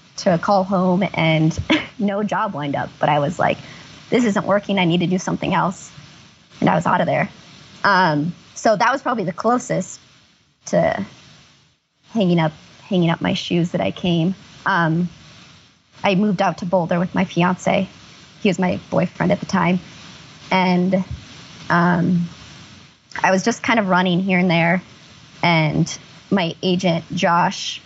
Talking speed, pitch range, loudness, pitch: 160 wpm, 170-195 Hz, -19 LUFS, 180 Hz